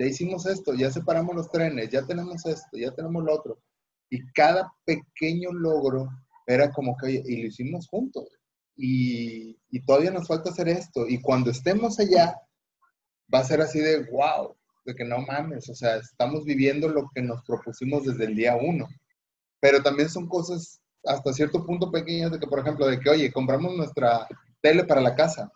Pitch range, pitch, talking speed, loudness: 130-170 Hz, 150 Hz, 185 wpm, -25 LUFS